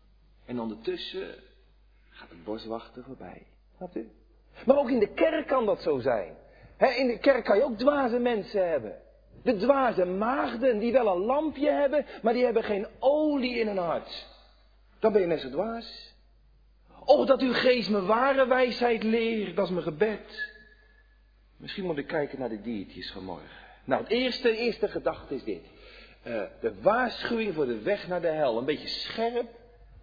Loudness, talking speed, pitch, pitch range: -27 LUFS, 170 wpm, 235 Hz, 200-270 Hz